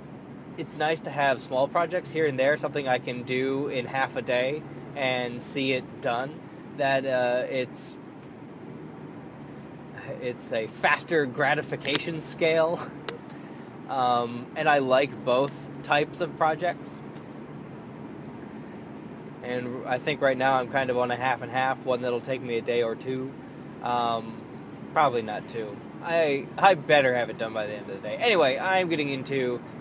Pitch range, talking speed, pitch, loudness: 120-145 Hz, 155 wpm, 130 Hz, -26 LUFS